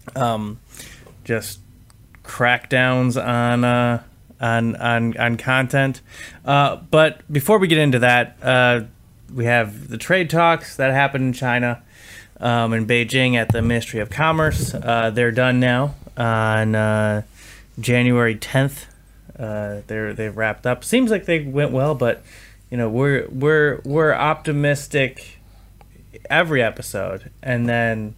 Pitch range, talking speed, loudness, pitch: 110-135 Hz, 135 wpm, -19 LUFS, 120 Hz